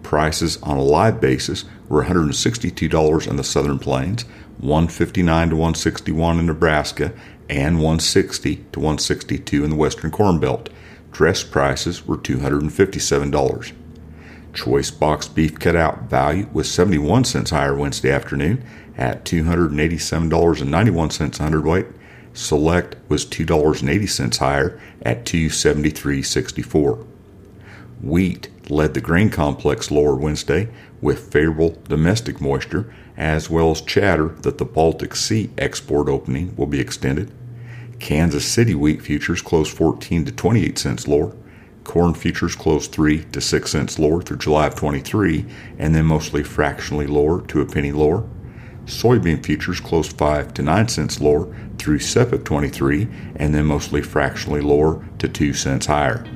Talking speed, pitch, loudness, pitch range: 135 wpm, 80 Hz, -19 LUFS, 75-90 Hz